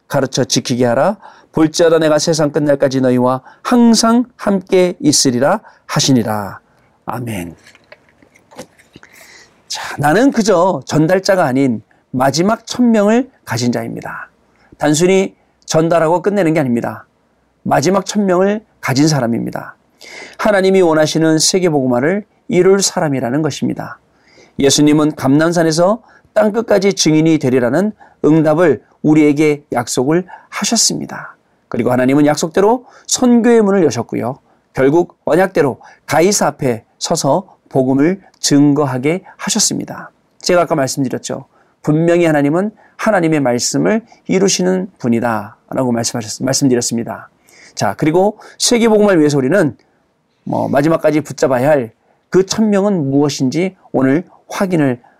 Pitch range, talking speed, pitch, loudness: 130-195 Hz, 295 characters per minute, 155 Hz, -14 LUFS